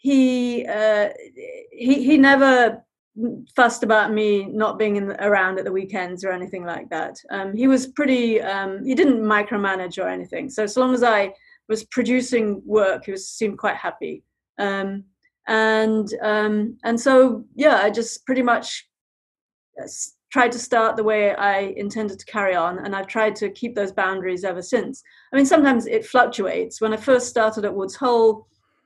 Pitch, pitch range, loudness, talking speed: 220 Hz, 200-250 Hz, -20 LUFS, 175 wpm